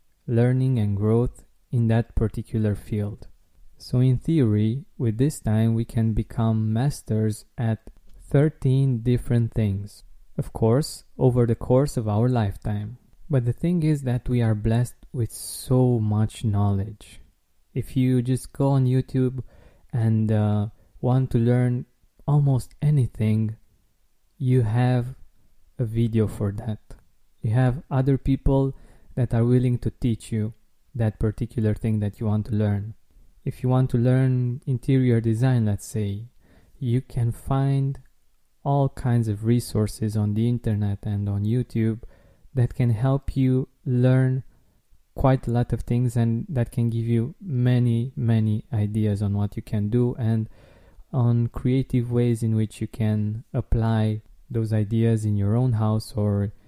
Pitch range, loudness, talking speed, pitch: 110-125 Hz, -24 LUFS, 145 wpm, 115 Hz